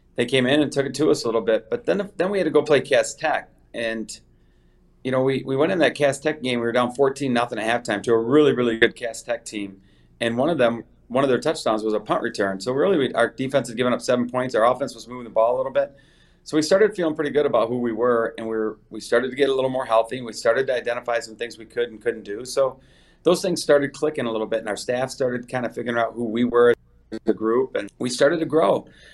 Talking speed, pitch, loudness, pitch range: 280 wpm, 125 Hz, -22 LUFS, 115-140 Hz